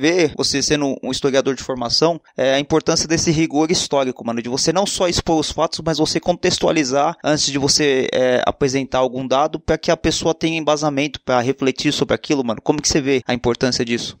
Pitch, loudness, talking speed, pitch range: 145 Hz, -18 LUFS, 205 wpm, 130-160 Hz